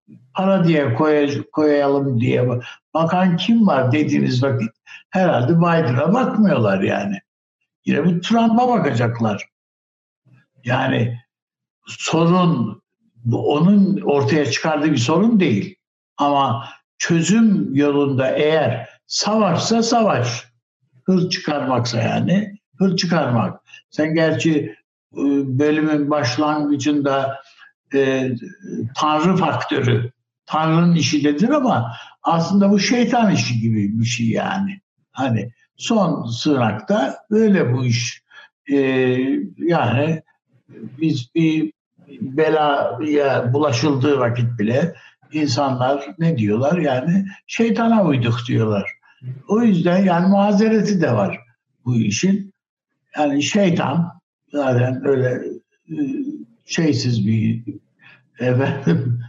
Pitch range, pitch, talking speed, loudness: 125-185 Hz, 150 Hz, 95 wpm, -18 LUFS